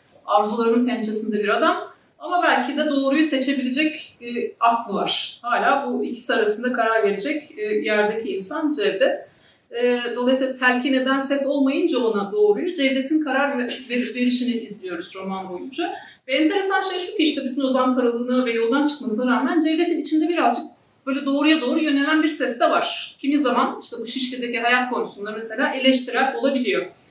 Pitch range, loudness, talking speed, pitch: 235-305 Hz, -21 LUFS, 160 wpm, 265 Hz